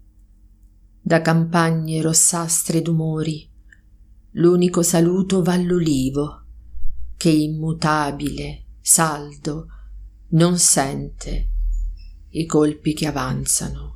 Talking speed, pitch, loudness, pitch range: 75 wpm, 155 Hz, -19 LUFS, 100-165 Hz